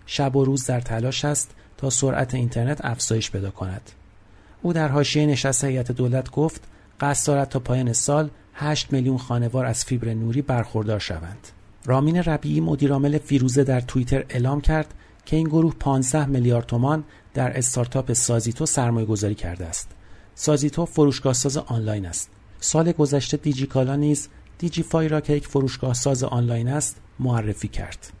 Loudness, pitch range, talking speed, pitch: -23 LUFS, 110-145 Hz, 155 wpm, 130 Hz